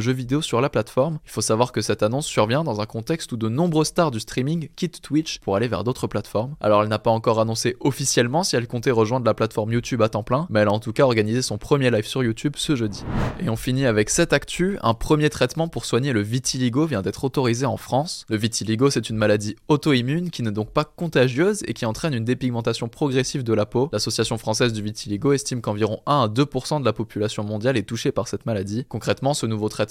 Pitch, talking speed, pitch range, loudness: 120 Hz, 240 wpm, 110-140 Hz, -22 LUFS